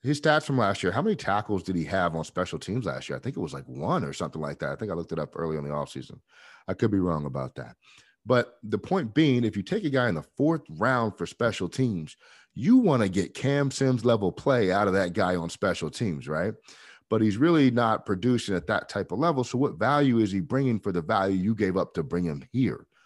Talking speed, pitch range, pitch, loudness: 260 wpm, 90-130 Hz, 110 Hz, -26 LUFS